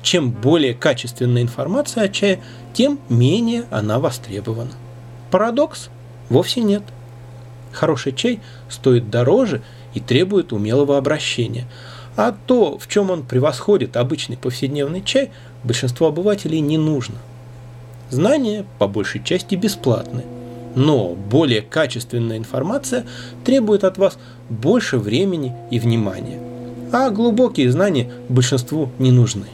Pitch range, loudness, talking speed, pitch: 120-165 Hz, -18 LUFS, 115 wpm, 125 Hz